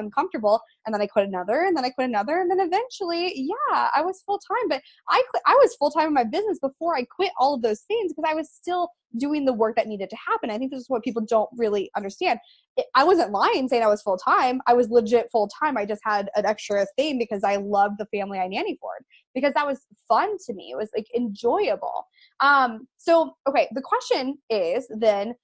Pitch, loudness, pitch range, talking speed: 260 Hz, -23 LUFS, 220-335 Hz, 230 wpm